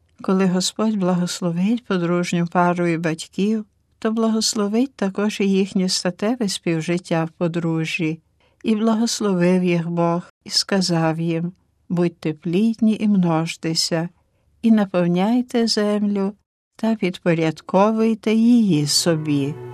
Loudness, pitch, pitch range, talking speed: -20 LUFS, 185 Hz, 170-215 Hz, 105 wpm